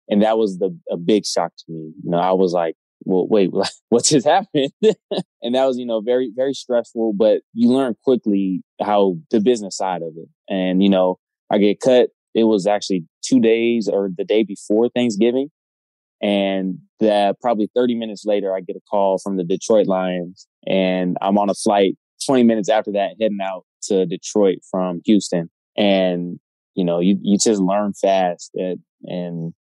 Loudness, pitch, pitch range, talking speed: -19 LUFS, 100 Hz, 95-115 Hz, 185 wpm